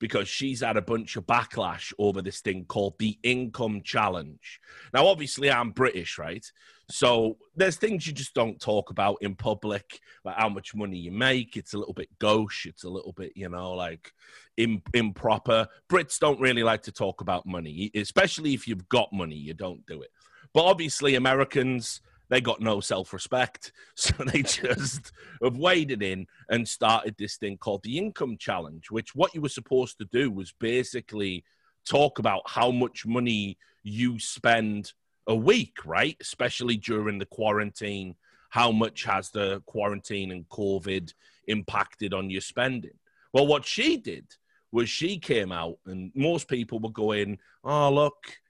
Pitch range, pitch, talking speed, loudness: 100-130 Hz, 110 Hz, 170 wpm, -27 LUFS